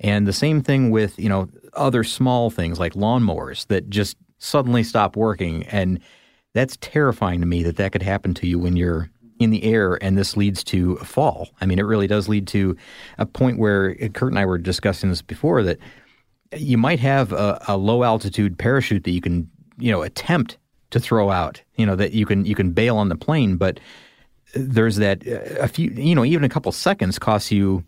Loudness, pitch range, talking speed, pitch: -20 LUFS, 95-115 Hz, 210 wpm, 100 Hz